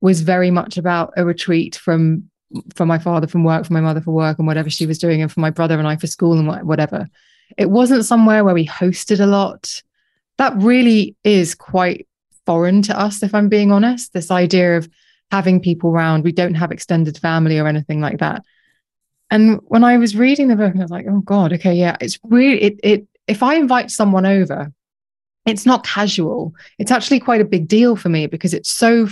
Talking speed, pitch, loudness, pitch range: 210 wpm, 185 Hz, -15 LUFS, 165-215 Hz